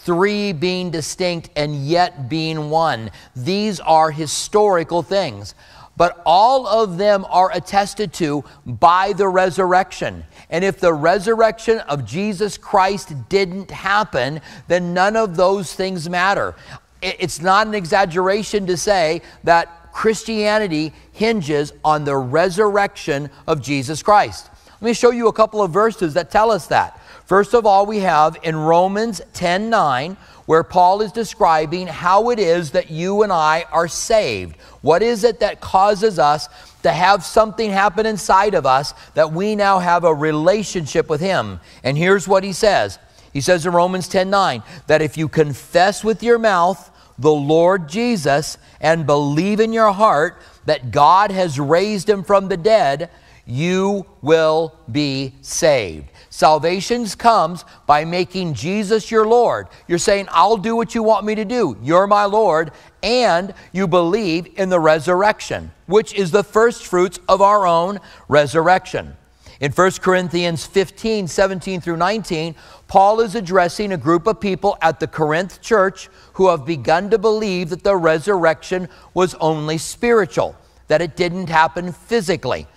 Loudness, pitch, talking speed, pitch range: -17 LUFS, 180 Hz, 155 wpm, 160-205 Hz